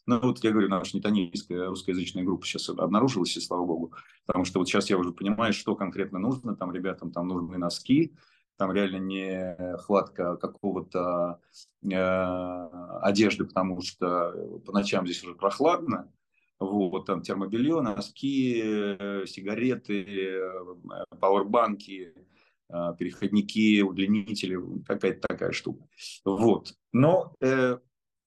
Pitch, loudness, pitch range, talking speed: 95 Hz, -28 LUFS, 90-100 Hz, 120 wpm